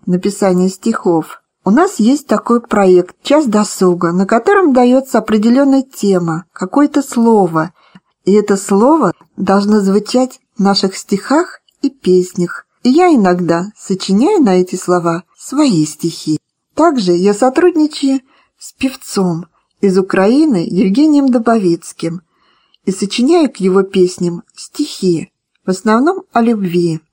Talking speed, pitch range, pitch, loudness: 120 wpm, 180-260 Hz, 205 Hz, -13 LUFS